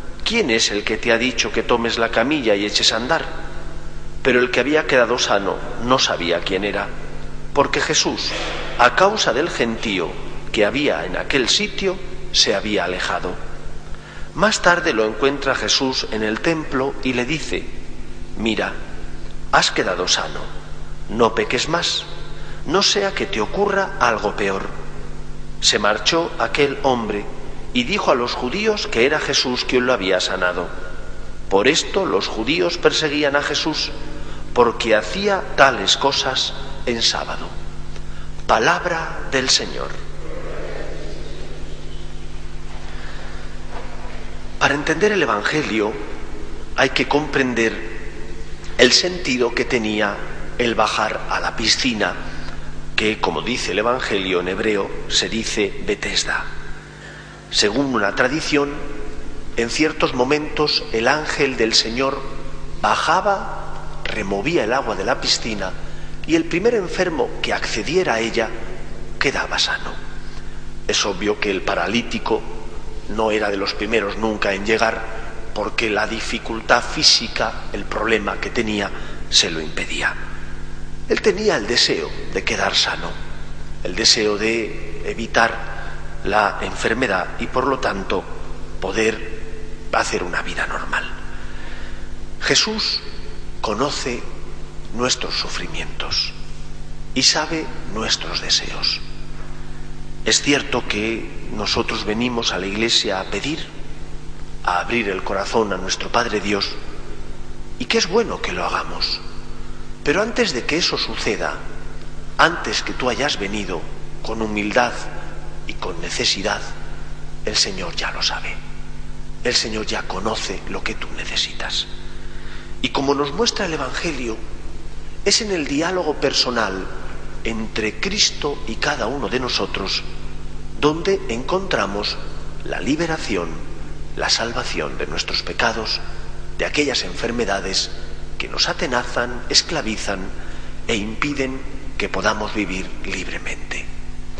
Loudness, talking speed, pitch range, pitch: -19 LUFS, 125 wpm, 100-145 Hz, 115 Hz